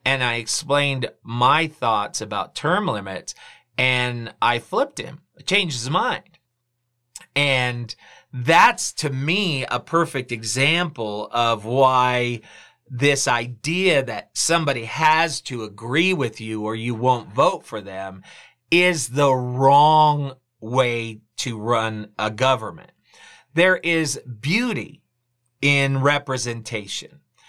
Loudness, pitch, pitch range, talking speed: -20 LUFS, 130 Hz, 120-145 Hz, 115 wpm